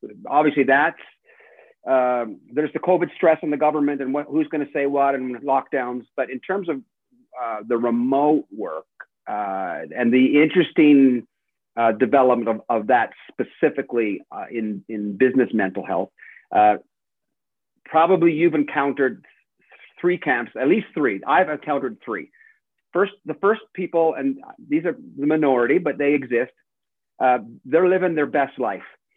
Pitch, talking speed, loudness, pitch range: 140 Hz, 150 wpm, -21 LUFS, 125-160 Hz